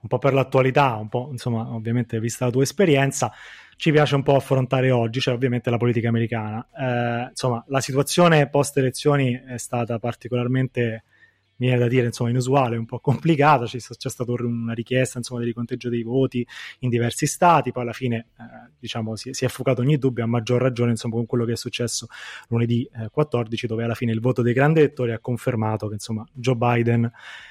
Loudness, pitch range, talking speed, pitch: -22 LUFS, 115-130 Hz, 200 wpm, 125 Hz